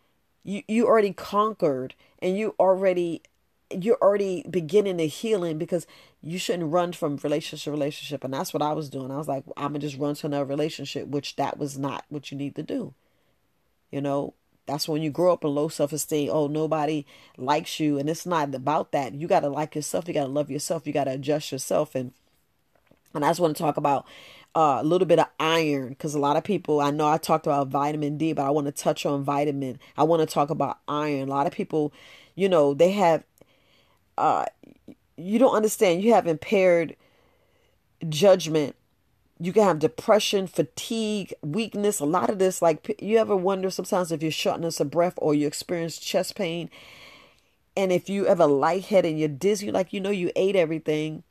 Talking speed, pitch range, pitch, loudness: 200 wpm, 145-180 Hz, 155 Hz, -25 LUFS